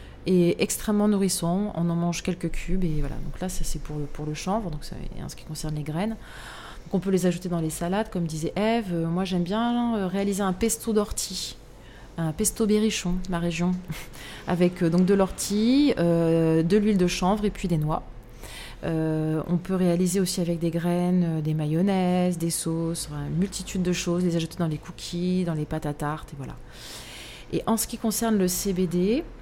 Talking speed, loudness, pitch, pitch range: 210 wpm, -26 LUFS, 175 Hz, 160-195 Hz